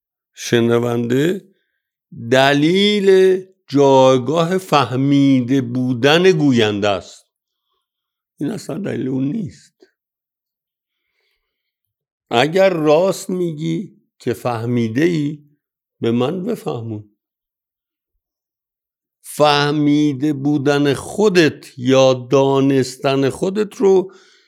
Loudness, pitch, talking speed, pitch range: -16 LUFS, 145 Hz, 70 wpm, 130-180 Hz